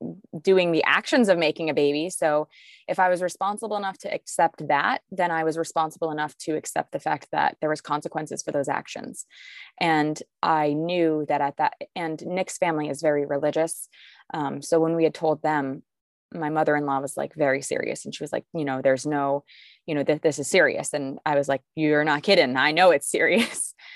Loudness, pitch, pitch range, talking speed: -24 LUFS, 155 Hz, 150-175 Hz, 205 wpm